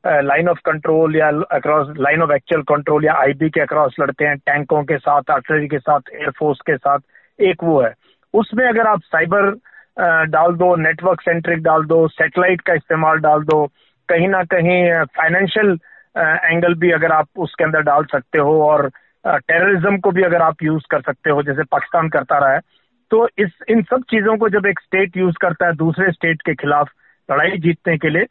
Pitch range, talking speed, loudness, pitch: 150-180 Hz, 200 wpm, -16 LUFS, 160 Hz